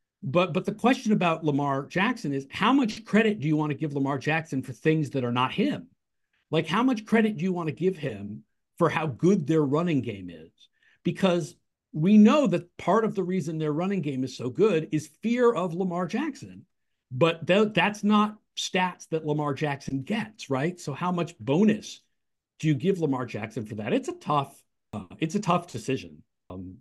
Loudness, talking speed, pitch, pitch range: -26 LUFS, 200 wpm, 165 Hz, 140-200 Hz